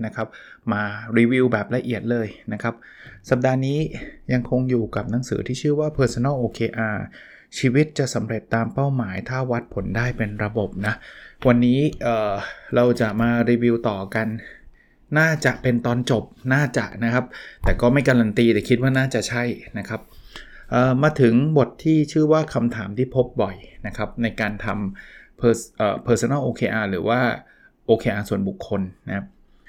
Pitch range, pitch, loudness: 110-130 Hz, 120 Hz, -22 LUFS